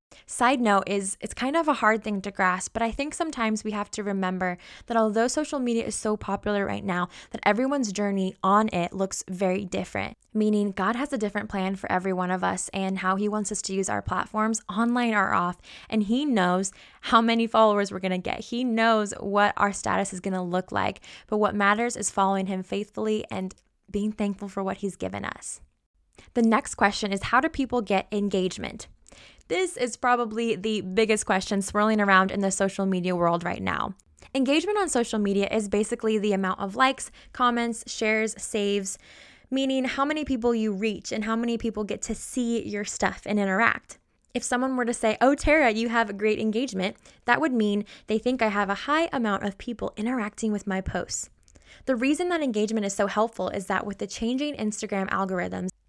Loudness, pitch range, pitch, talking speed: -26 LUFS, 195-235 Hz, 215 Hz, 205 wpm